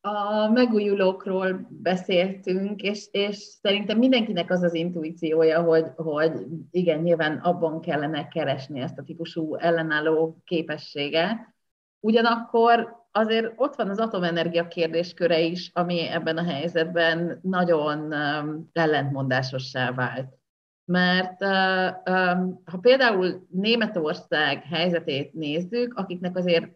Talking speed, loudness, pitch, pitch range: 100 wpm, -24 LUFS, 175 Hz, 160-195 Hz